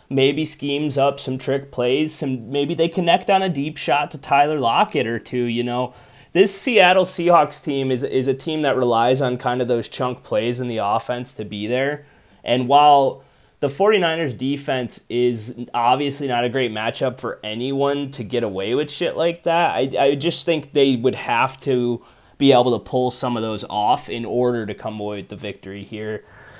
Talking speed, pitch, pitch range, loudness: 200 wpm, 130 Hz, 120-145 Hz, -20 LUFS